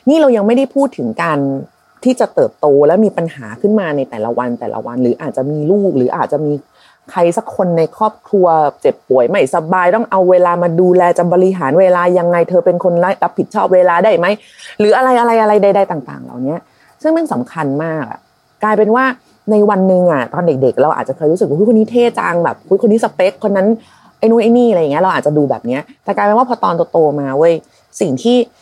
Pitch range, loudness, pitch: 165-225 Hz, -13 LUFS, 185 Hz